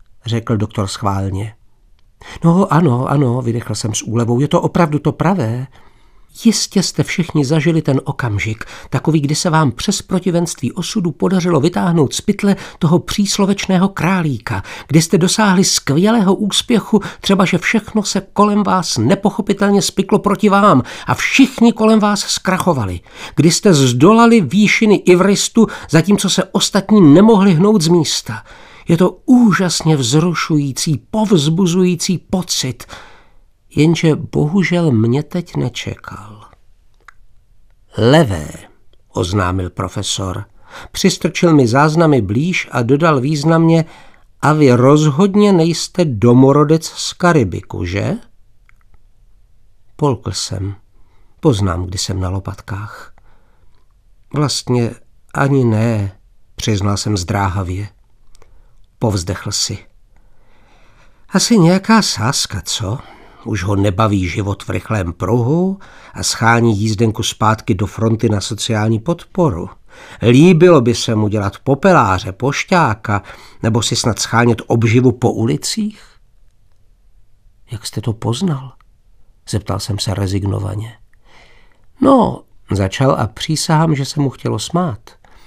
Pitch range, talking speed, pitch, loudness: 105-180 Hz, 115 wpm, 130 Hz, -14 LUFS